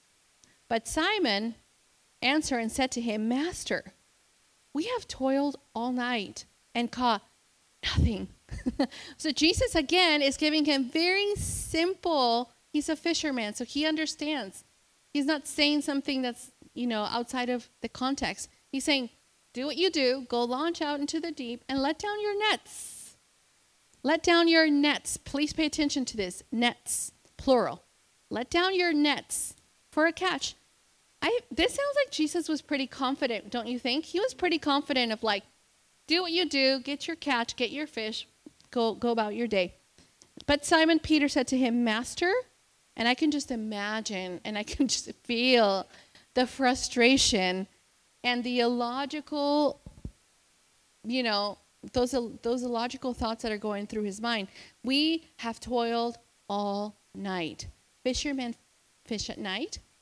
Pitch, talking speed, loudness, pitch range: 265 Hz, 150 wpm, -29 LUFS, 235-300 Hz